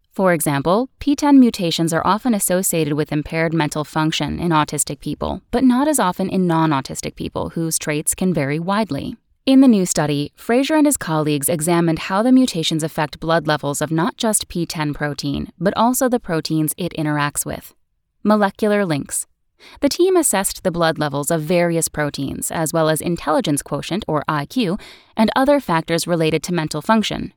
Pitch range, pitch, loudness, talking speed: 155-215 Hz, 170 Hz, -18 LUFS, 170 wpm